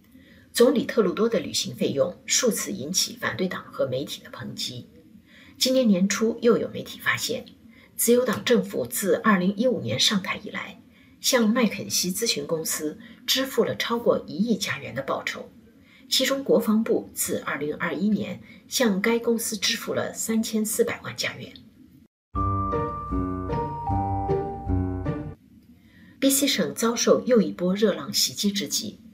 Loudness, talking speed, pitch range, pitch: -24 LUFS, 195 characters per minute, 165-240 Hz, 220 Hz